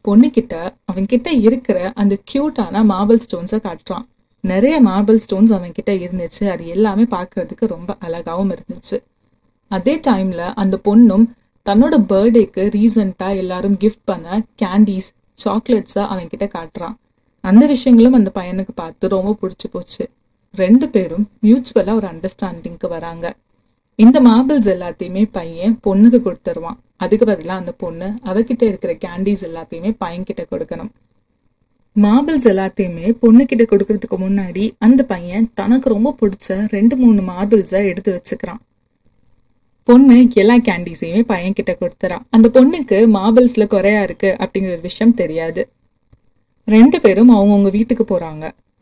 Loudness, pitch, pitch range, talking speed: -14 LUFS, 205 Hz, 185-230 Hz, 115 wpm